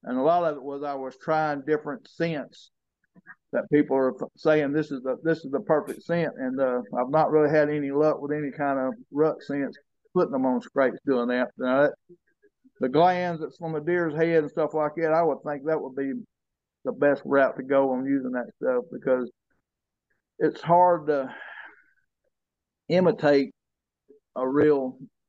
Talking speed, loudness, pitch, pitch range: 185 wpm, -25 LUFS, 150 Hz, 135-165 Hz